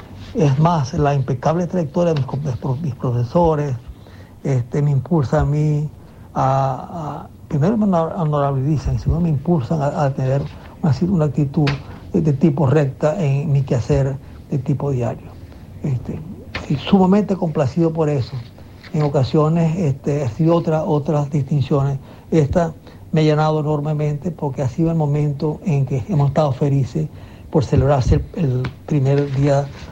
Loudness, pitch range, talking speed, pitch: -19 LUFS, 135-160 Hz, 145 wpm, 145 Hz